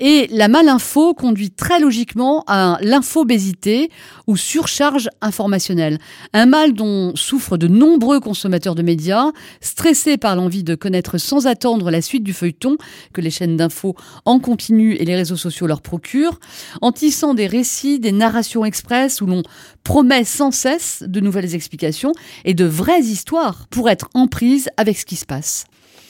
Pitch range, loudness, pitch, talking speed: 180-275 Hz, -16 LUFS, 220 Hz, 165 wpm